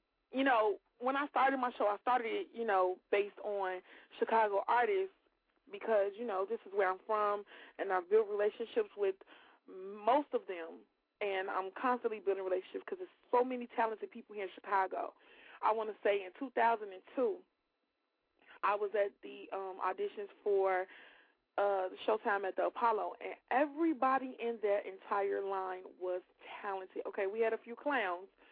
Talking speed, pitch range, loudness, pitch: 165 wpm, 195-260 Hz, -36 LUFS, 215 Hz